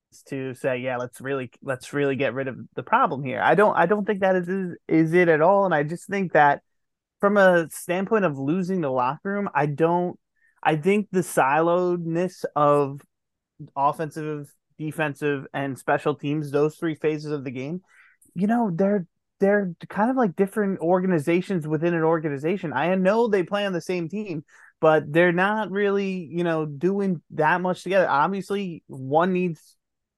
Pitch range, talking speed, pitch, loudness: 150-190 Hz, 175 wpm, 170 Hz, -23 LUFS